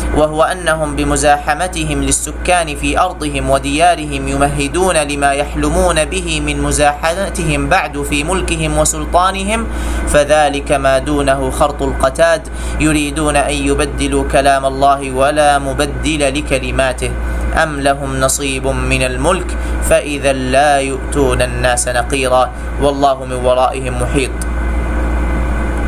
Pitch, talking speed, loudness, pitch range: 145 Hz, 100 wpm, -14 LUFS, 135-155 Hz